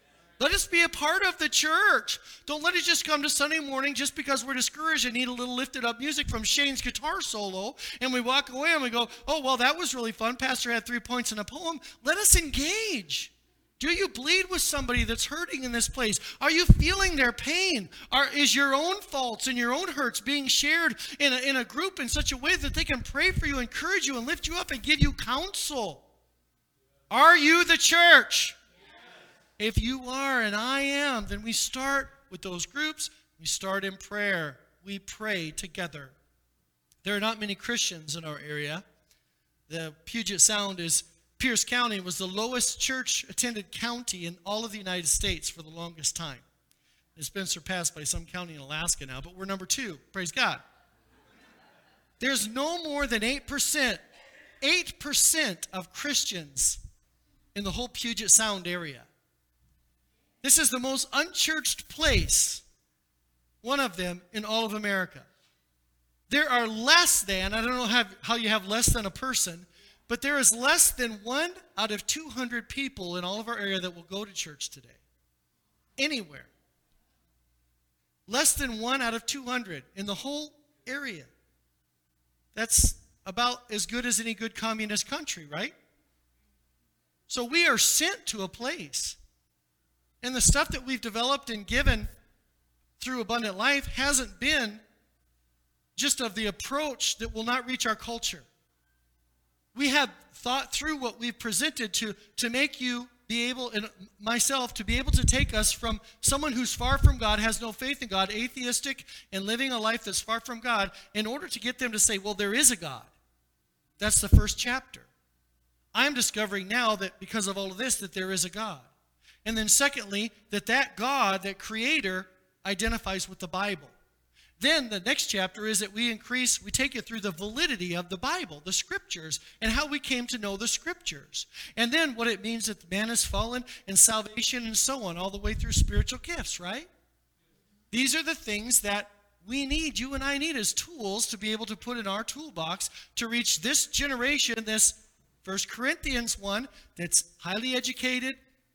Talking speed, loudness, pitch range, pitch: 180 wpm, -27 LUFS, 185-270 Hz, 225 Hz